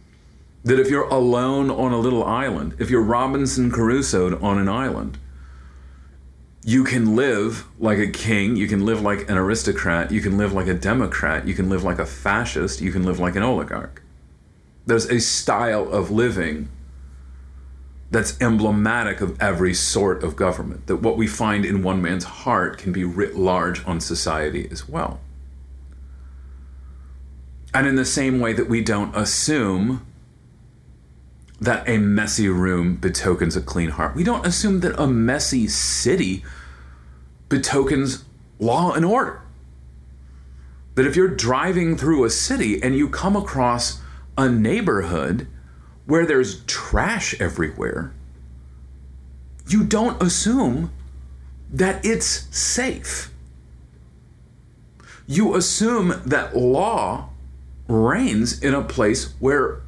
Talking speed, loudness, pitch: 135 wpm, -20 LUFS, 90 Hz